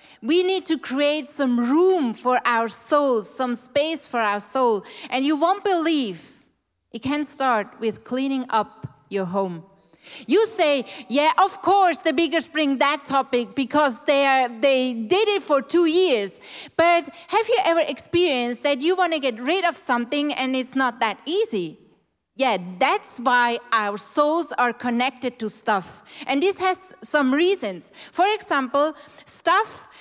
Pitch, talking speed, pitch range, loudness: 280 Hz, 160 wpm, 245-330 Hz, -21 LUFS